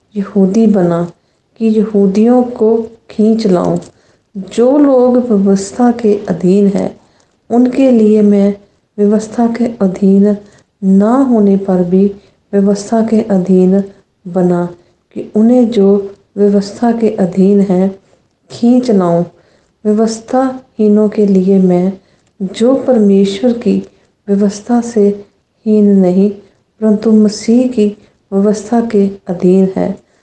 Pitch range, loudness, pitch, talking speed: 195-225 Hz, -11 LUFS, 205 Hz, 105 wpm